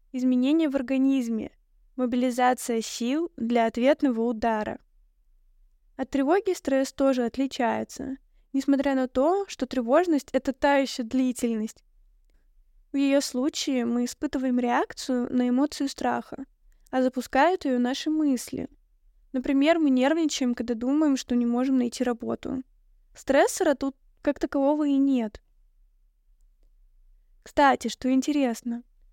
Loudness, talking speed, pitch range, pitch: -25 LUFS, 115 wpm, 250-285 Hz, 265 Hz